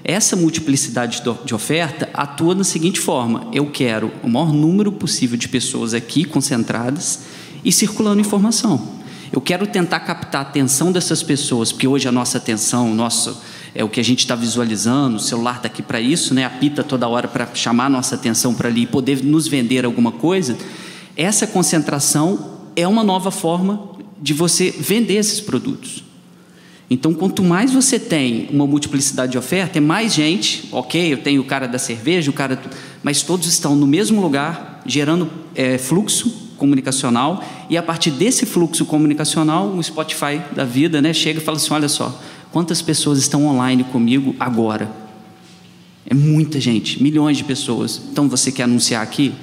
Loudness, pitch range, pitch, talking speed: -17 LUFS, 125-175 Hz, 145 Hz, 170 wpm